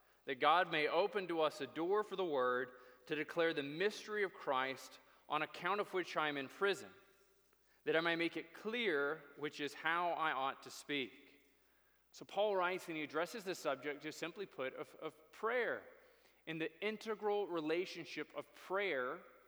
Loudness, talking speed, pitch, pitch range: -40 LUFS, 180 wpm, 160 Hz, 145-200 Hz